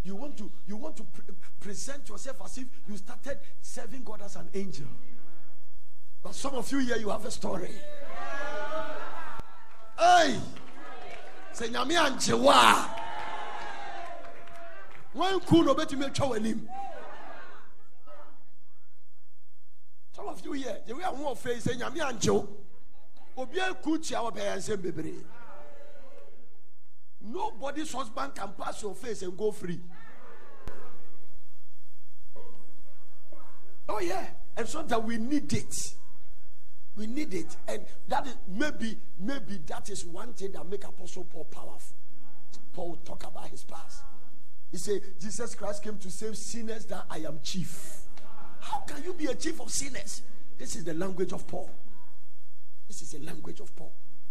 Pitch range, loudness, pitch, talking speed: 200-290 Hz, -32 LUFS, 230 Hz, 125 wpm